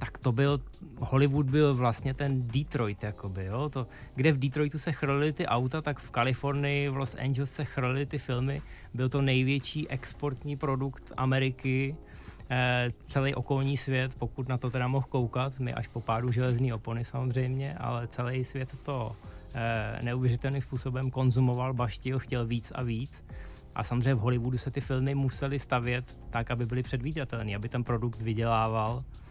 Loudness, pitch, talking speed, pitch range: -31 LUFS, 130 Hz, 165 wpm, 120-135 Hz